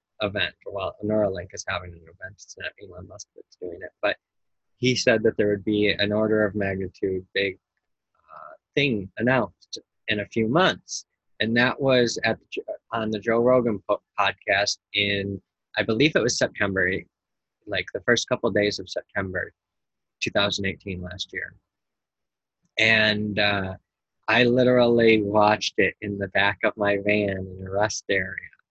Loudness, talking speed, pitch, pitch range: -23 LUFS, 165 wpm, 105 Hz, 95-110 Hz